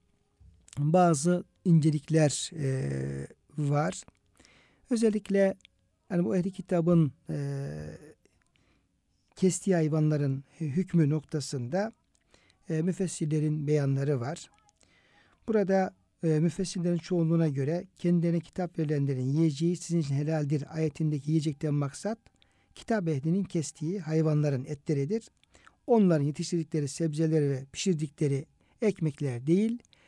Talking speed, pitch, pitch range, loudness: 90 wpm, 160 Hz, 145-175 Hz, -29 LUFS